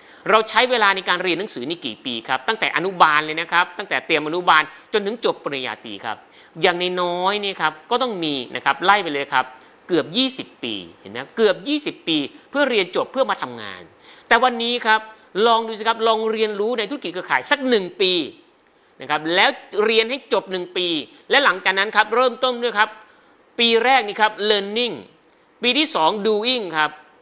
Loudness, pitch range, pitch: -19 LUFS, 175-250 Hz, 215 Hz